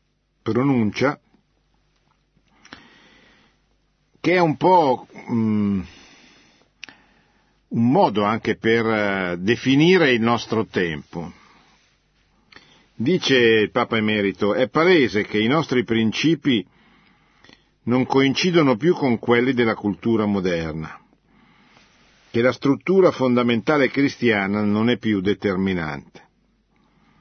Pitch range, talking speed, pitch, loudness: 105-130 Hz, 90 wpm, 115 Hz, -20 LUFS